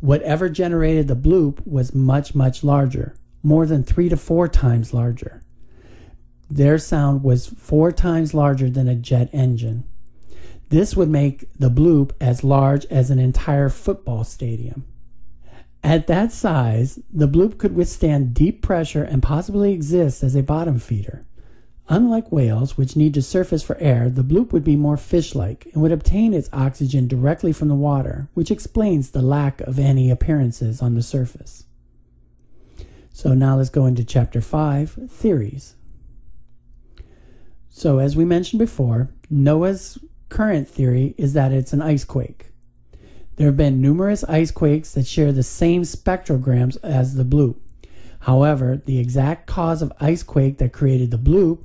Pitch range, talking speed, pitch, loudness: 125-160 Hz, 155 wpm, 140 Hz, -19 LUFS